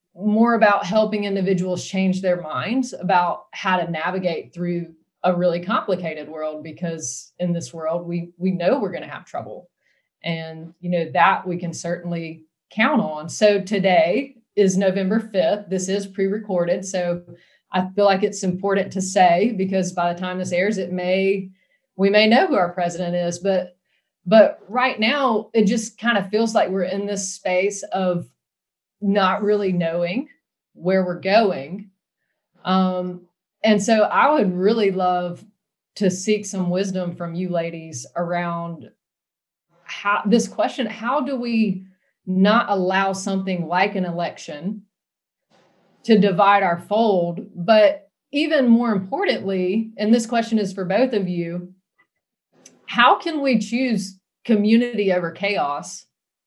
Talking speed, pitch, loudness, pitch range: 150 wpm, 190 Hz, -20 LUFS, 175-210 Hz